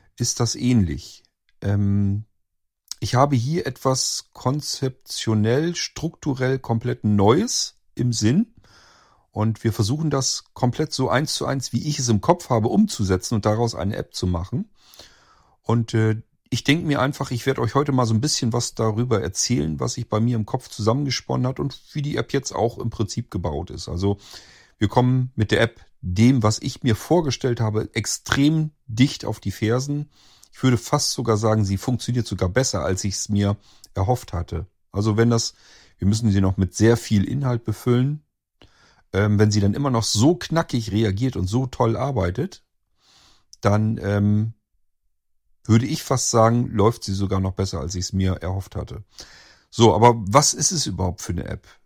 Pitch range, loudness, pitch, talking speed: 100-130 Hz, -22 LUFS, 115 Hz, 175 wpm